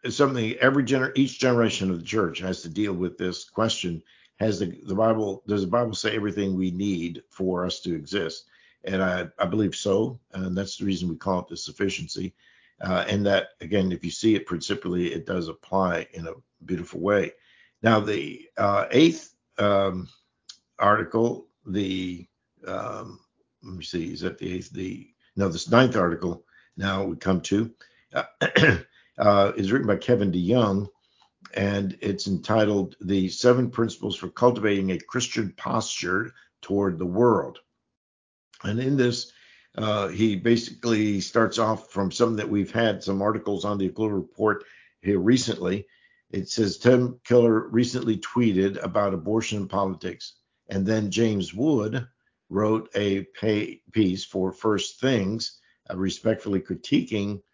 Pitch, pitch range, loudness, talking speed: 100 Hz, 95-110 Hz, -25 LUFS, 155 wpm